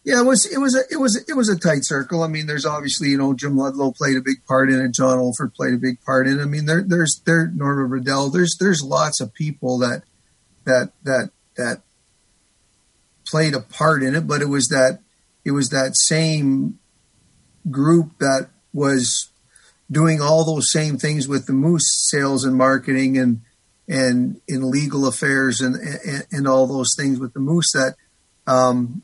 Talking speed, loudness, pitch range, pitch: 195 wpm, -19 LUFS, 130-155 Hz, 140 Hz